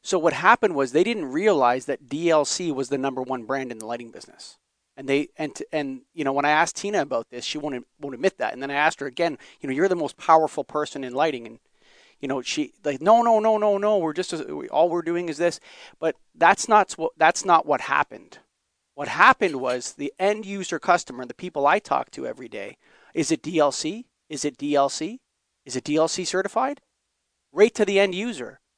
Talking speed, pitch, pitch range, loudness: 220 wpm, 155 Hz, 140-195 Hz, -23 LUFS